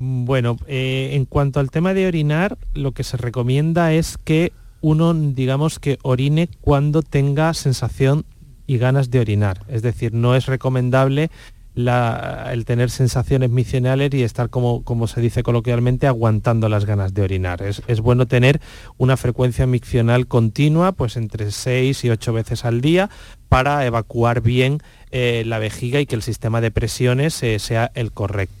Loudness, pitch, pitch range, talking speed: -19 LUFS, 125 Hz, 115-140 Hz, 165 wpm